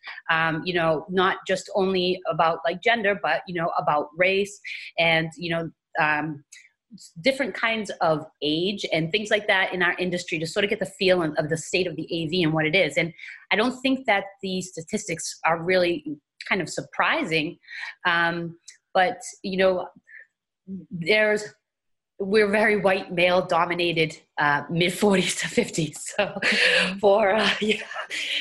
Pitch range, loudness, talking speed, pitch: 165-200 Hz, -23 LUFS, 160 wpm, 180 Hz